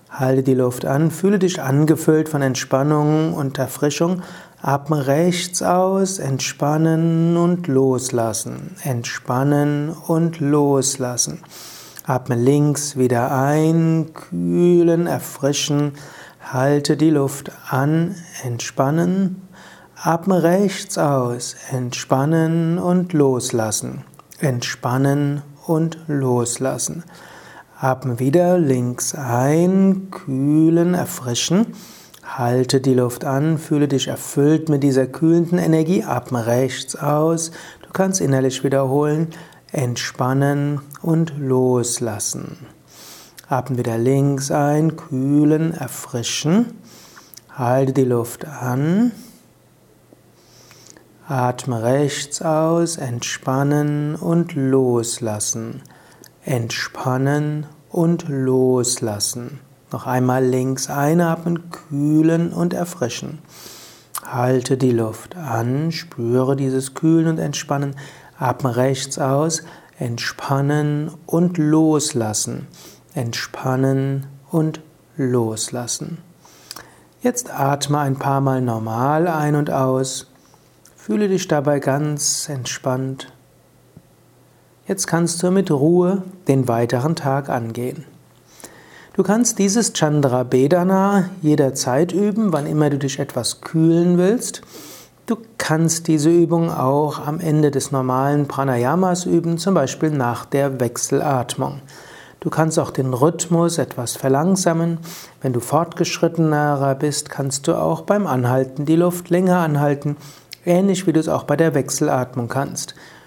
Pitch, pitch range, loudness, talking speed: 145 Hz, 130-165 Hz, -19 LUFS, 100 wpm